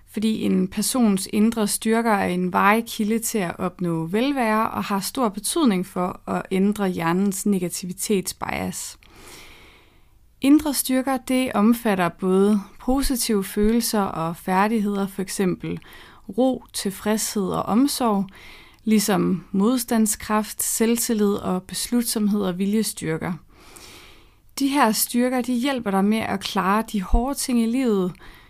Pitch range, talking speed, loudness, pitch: 195-235 Hz, 120 wpm, -22 LUFS, 210 Hz